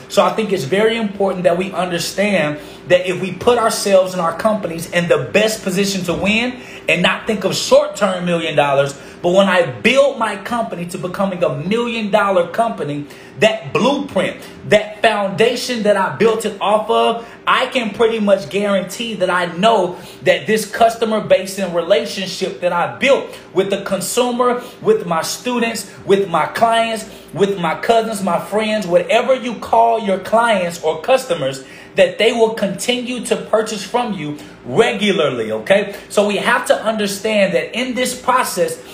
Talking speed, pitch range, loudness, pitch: 170 wpm, 180-230 Hz, -16 LUFS, 205 Hz